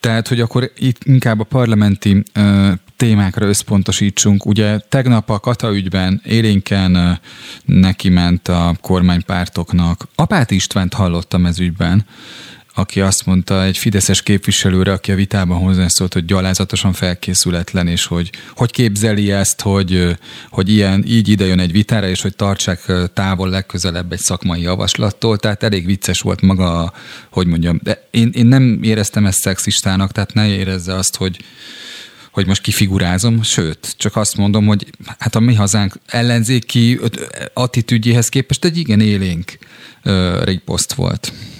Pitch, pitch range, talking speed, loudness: 100 Hz, 95-110 Hz, 140 wpm, -14 LUFS